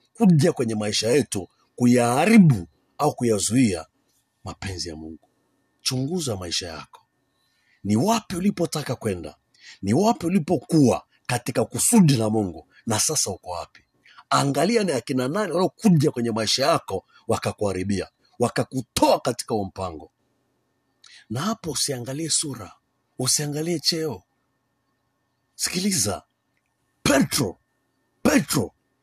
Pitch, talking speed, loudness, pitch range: 135 Hz, 100 wpm, -22 LUFS, 110-165 Hz